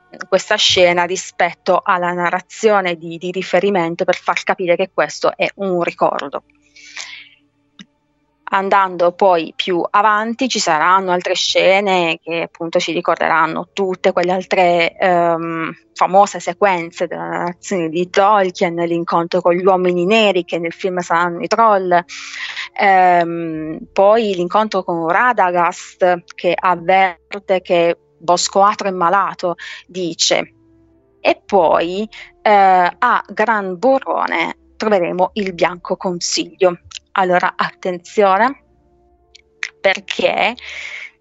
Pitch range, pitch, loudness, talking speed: 170-195 Hz, 180 Hz, -16 LUFS, 110 wpm